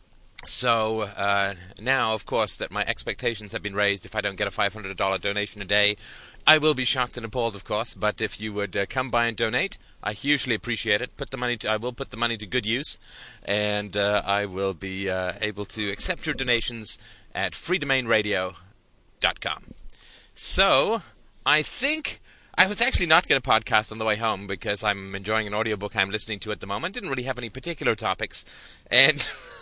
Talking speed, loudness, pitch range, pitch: 200 wpm, -24 LUFS, 100-120 Hz, 105 Hz